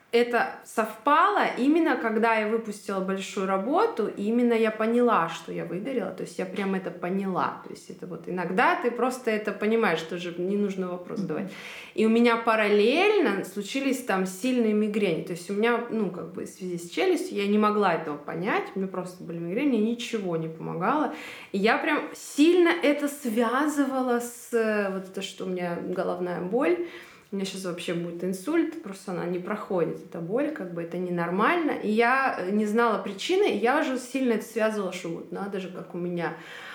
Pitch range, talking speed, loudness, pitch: 185-245 Hz, 190 wpm, -26 LUFS, 215 Hz